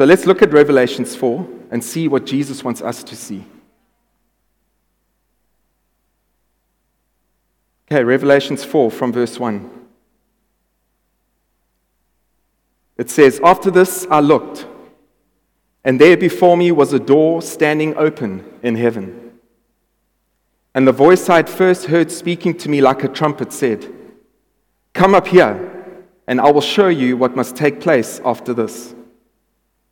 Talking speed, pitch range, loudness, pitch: 130 wpm, 125-175 Hz, -14 LUFS, 145 Hz